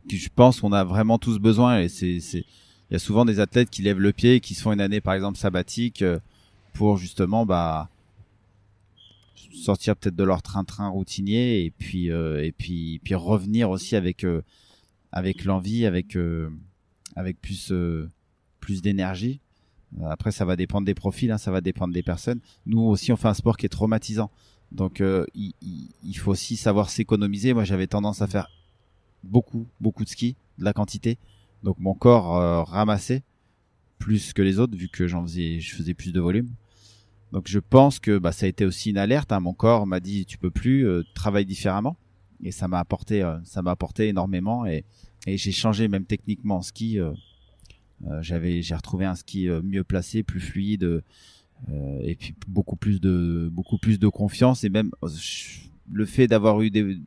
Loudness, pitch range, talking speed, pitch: -24 LUFS, 90-110 Hz, 195 wpm, 100 Hz